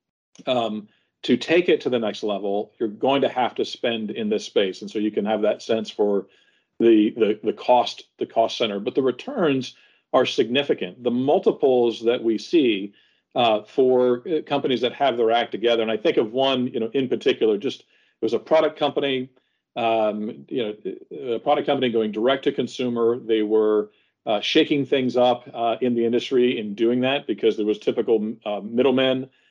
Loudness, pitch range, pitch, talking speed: -22 LUFS, 110-135 Hz, 120 Hz, 190 wpm